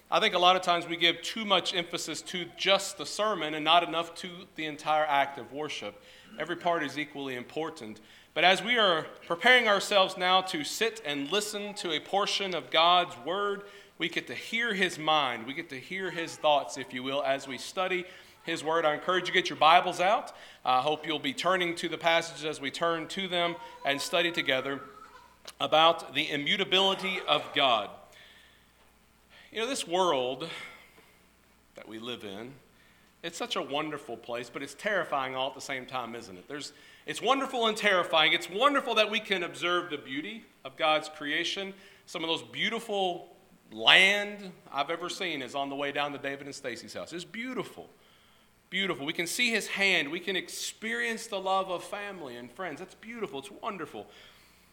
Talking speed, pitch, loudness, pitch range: 190 wpm, 170 Hz, -28 LUFS, 140-190 Hz